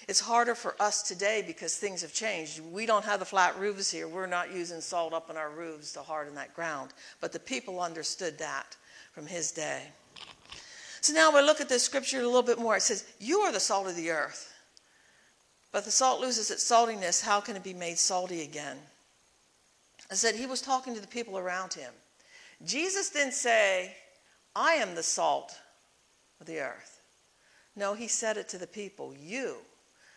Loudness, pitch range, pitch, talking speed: -30 LUFS, 175-245 Hz, 205 Hz, 195 wpm